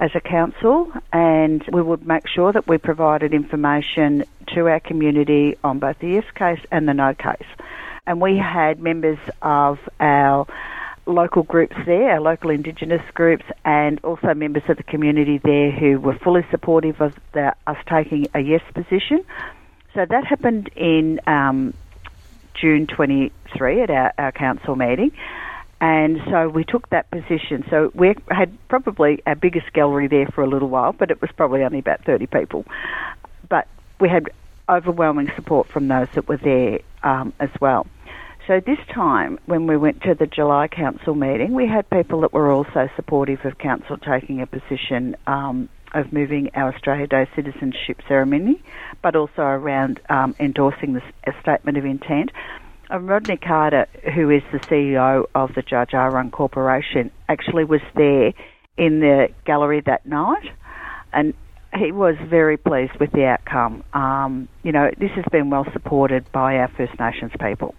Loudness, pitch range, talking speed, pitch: -19 LUFS, 140-170 Hz, 165 wpm, 150 Hz